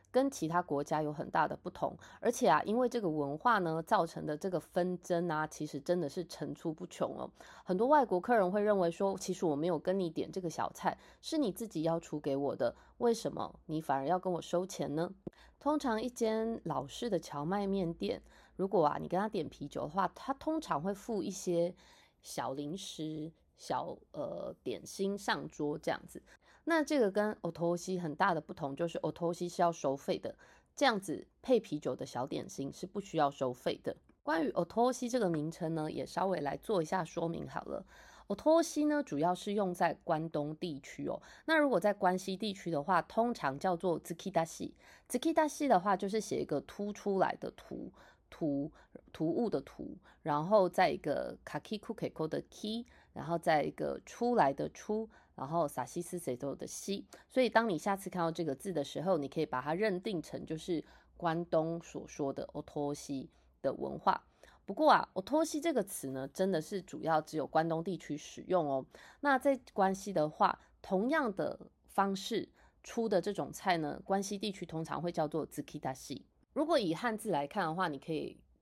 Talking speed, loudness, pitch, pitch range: 300 characters per minute, -35 LUFS, 180 Hz, 155-210 Hz